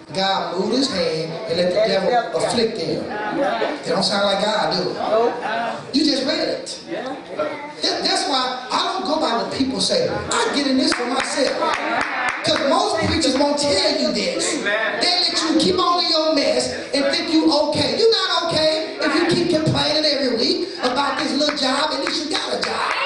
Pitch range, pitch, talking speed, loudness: 255-330 Hz, 295 Hz, 190 wpm, -19 LUFS